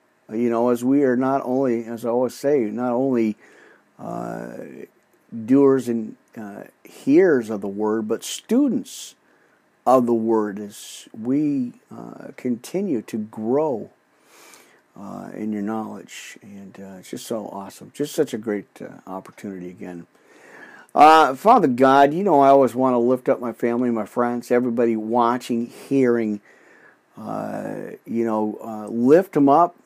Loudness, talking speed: -20 LUFS, 150 wpm